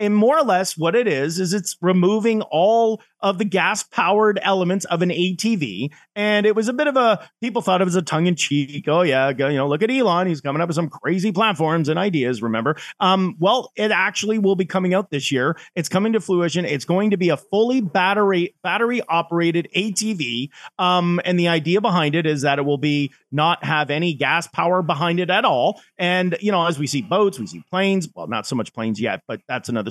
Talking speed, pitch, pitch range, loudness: 225 wpm, 180 Hz, 155-200 Hz, -20 LUFS